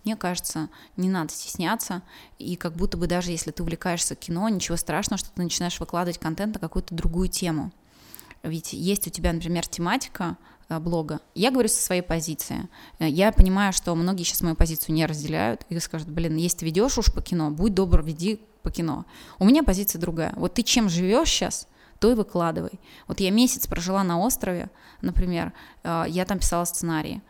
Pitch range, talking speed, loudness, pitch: 165-200 Hz, 180 wpm, -25 LUFS, 175 Hz